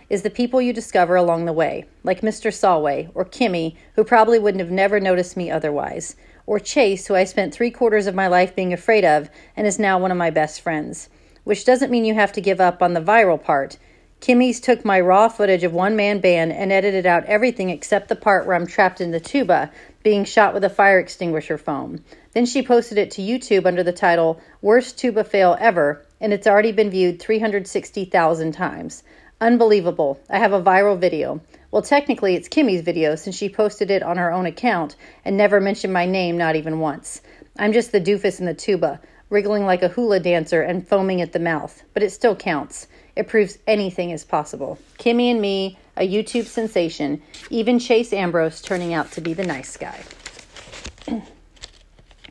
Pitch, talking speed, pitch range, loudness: 195 Hz, 195 wpm, 175-215 Hz, -19 LUFS